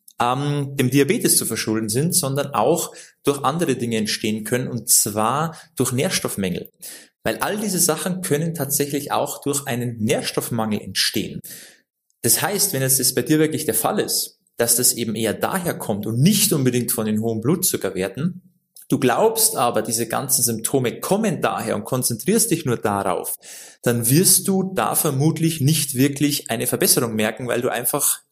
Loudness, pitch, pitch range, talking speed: -20 LUFS, 135 Hz, 115-155 Hz, 160 wpm